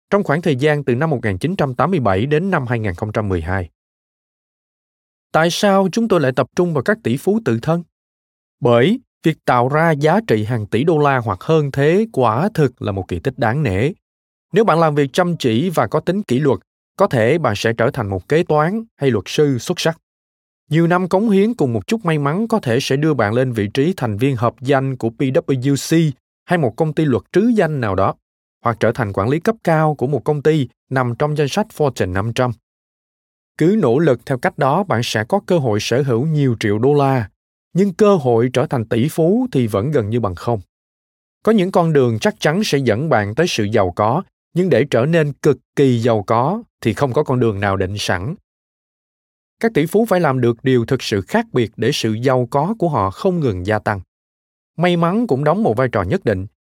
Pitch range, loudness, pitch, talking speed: 115-165 Hz, -17 LUFS, 135 Hz, 220 wpm